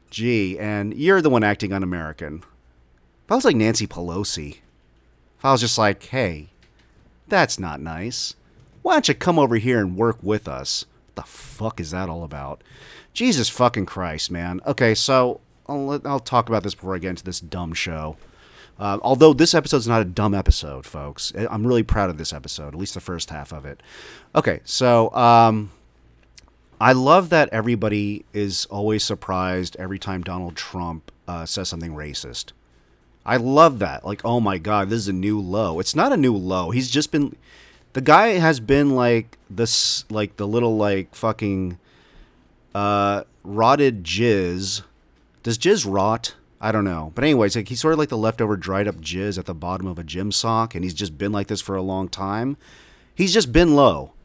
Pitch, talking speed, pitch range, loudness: 100 Hz, 190 wpm, 90-115 Hz, -21 LUFS